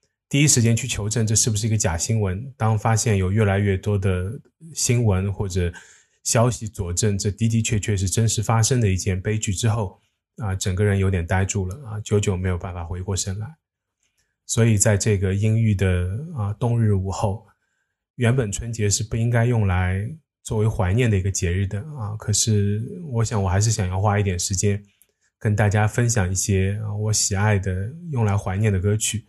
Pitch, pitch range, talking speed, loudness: 105 Hz, 100-115 Hz, 280 characters per minute, -22 LUFS